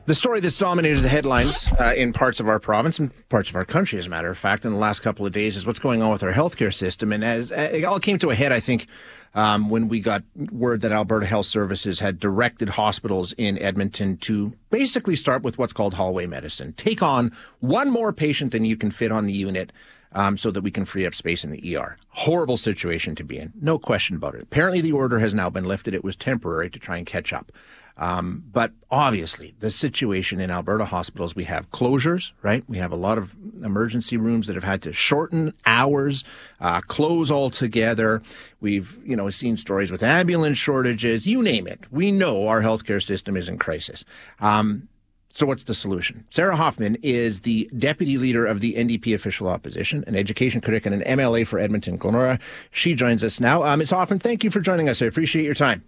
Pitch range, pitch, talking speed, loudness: 100-135 Hz, 110 Hz, 220 wpm, -22 LUFS